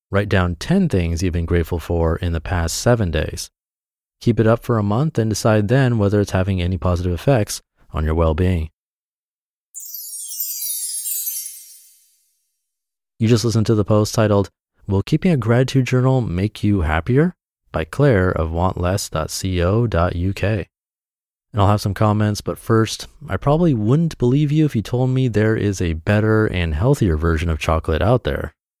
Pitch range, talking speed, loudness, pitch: 85-120 Hz, 165 wpm, -19 LUFS, 105 Hz